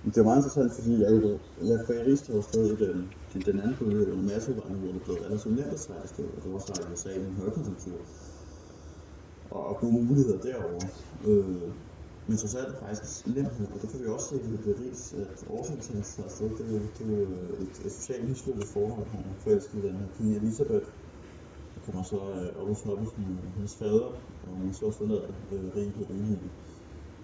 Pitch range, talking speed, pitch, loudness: 90-110 Hz, 225 wpm, 100 Hz, -31 LUFS